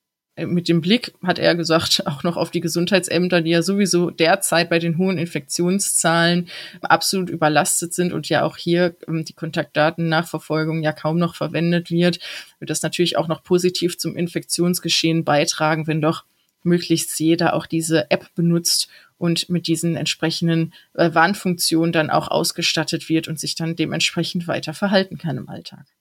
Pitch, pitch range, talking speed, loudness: 170 Hz, 160-175 Hz, 155 wpm, -19 LUFS